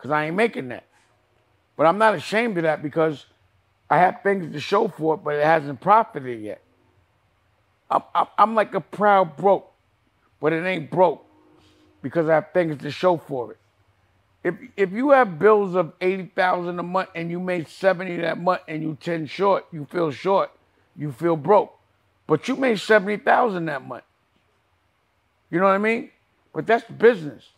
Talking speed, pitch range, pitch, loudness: 175 wpm, 150-195 Hz, 170 Hz, -21 LUFS